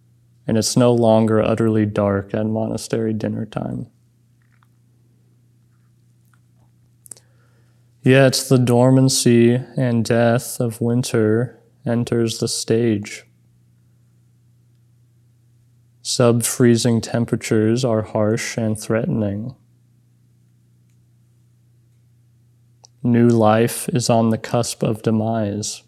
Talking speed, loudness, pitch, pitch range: 80 wpm, -18 LUFS, 120 Hz, 115-120 Hz